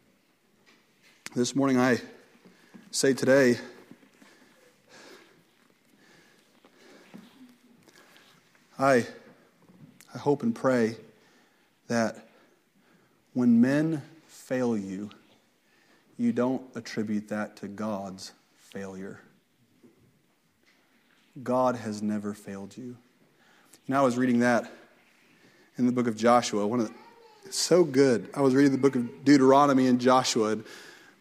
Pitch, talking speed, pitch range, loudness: 125 Hz, 100 wpm, 110-140 Hz, -26 LUFS